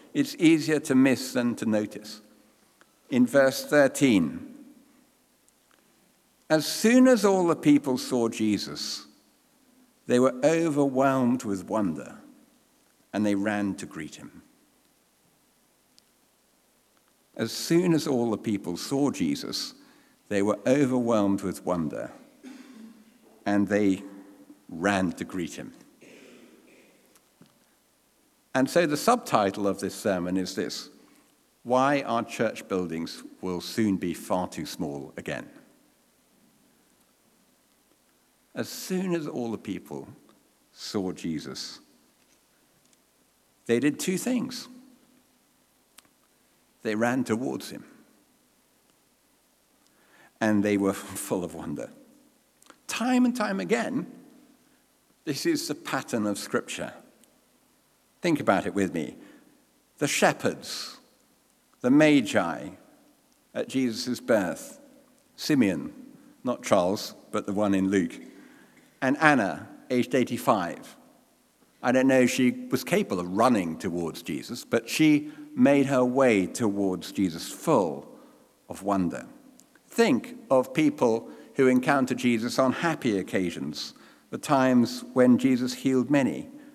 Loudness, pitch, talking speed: -26 LUFS, 145 Hz, 110 wpm